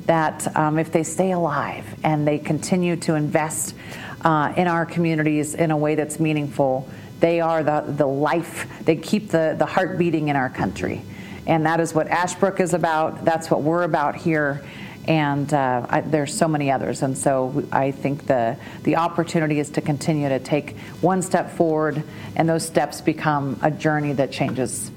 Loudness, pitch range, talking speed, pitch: -22 LUFS, 145-165 Hz, 180 wpm, 155 Hz